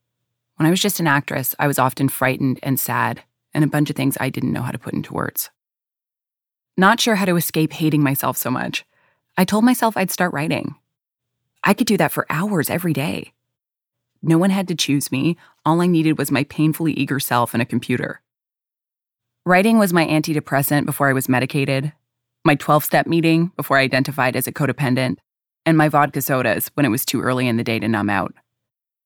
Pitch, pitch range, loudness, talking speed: 145 Hz, 130-165 Hz, -19 LUFS, 200 wpm